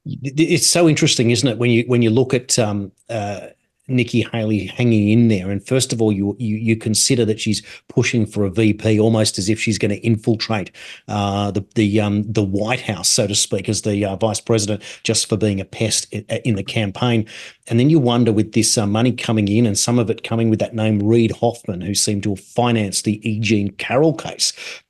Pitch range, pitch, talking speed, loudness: 105-120 Hz, 110 Hz, 220 wpm, -18 LUFS